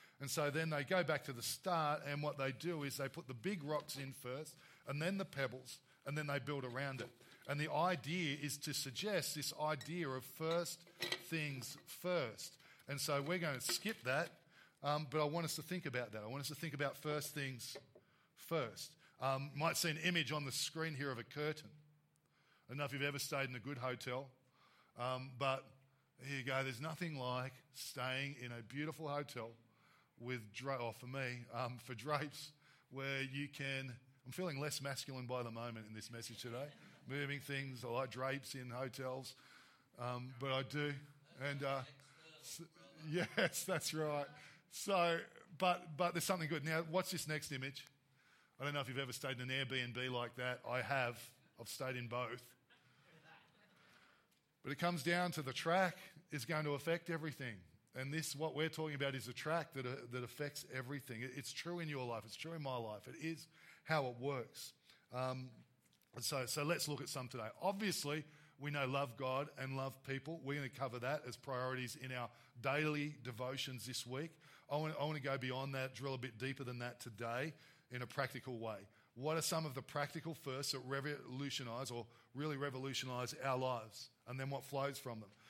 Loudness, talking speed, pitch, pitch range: -43 LUFS, 195 wpm, 140 Hz, 130-155 Hz